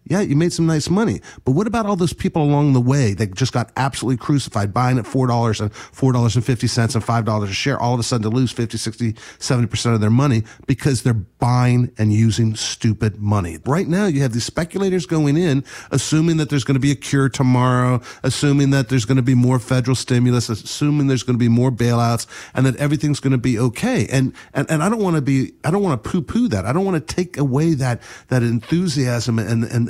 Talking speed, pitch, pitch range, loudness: 230 wpm, 130 Hz, 120-145 Hz, -18 LUFS